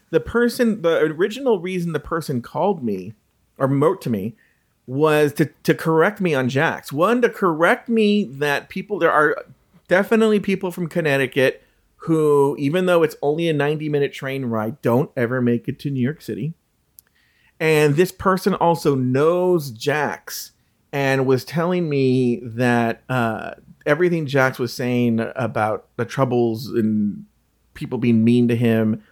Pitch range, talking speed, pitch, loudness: 125-175 Hz, 155 wpm, 145 Hz, -20 LUFS